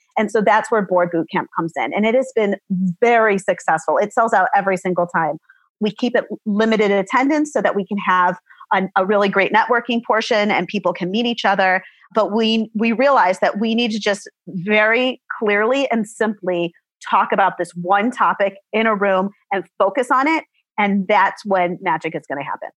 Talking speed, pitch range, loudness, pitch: 200 wpm, 185-225 Hz, -18 LUFS, 205 Hz